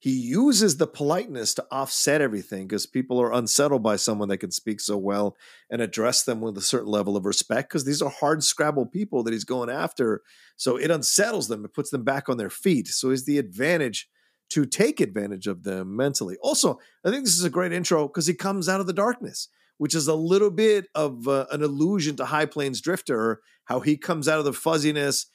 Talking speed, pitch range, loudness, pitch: 220 wpm, 120-170 Hz, -24 LUFS, 145 Hz